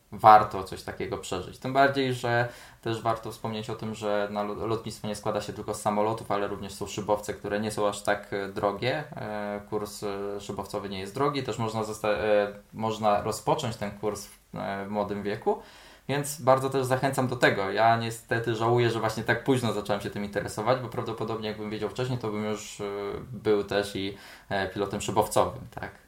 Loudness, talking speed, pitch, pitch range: -28 LUFS, 175 wpm, 105 Hz, 105-115 Hz